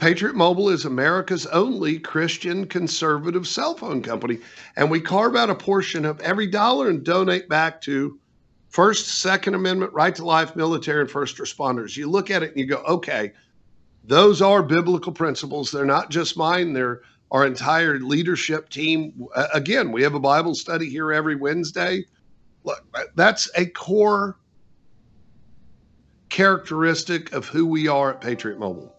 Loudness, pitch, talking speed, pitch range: -21 LUFS, 165 Hz, 155 wpm, 145-185 Hz